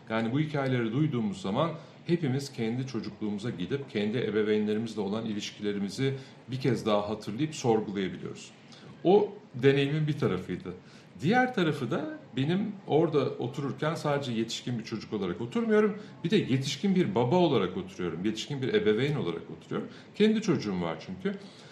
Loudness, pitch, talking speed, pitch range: -30 LUFS, 140 Hz, 140 wpm, 110-170 Hz